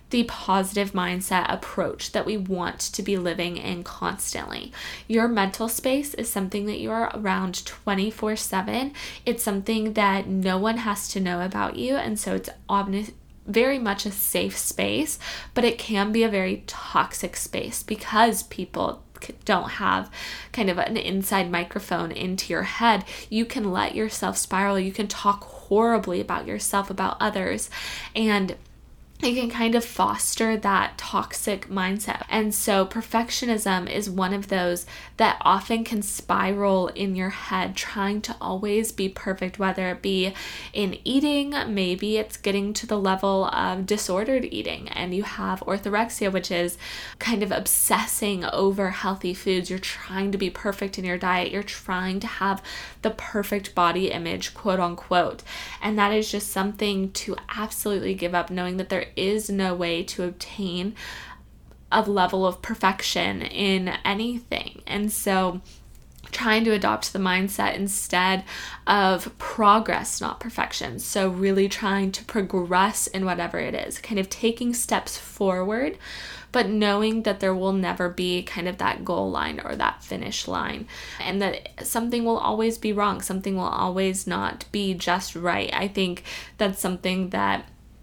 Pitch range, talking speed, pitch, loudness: 185-215 Hz, 155 wpm, 195 Hz, -25 LUFS